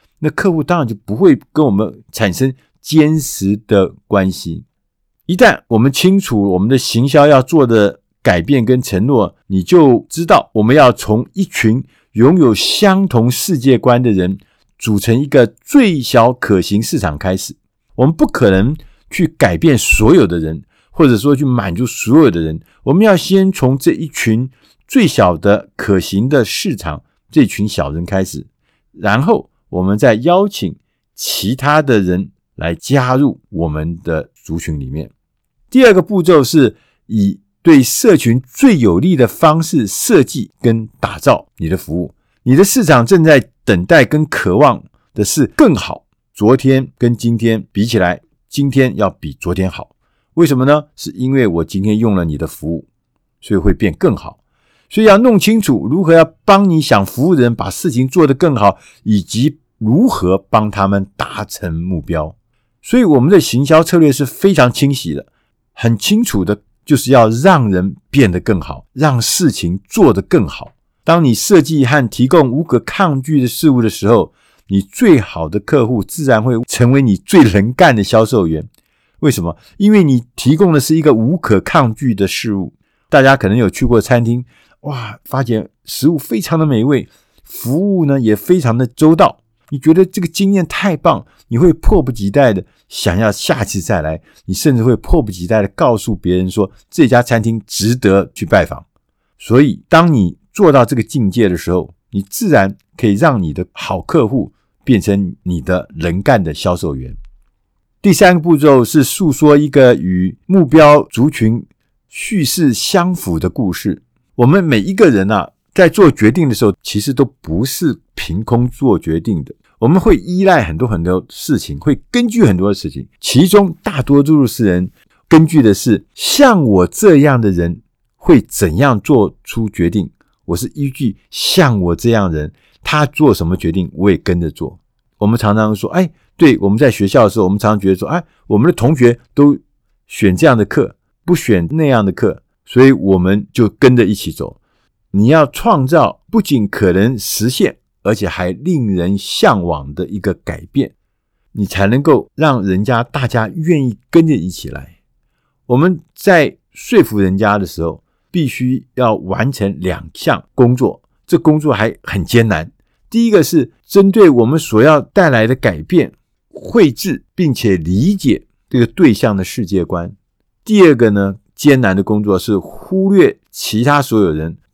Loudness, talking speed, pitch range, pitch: -12 LUFS, 245 characters per minute, 100-150 Hz, 115 Hz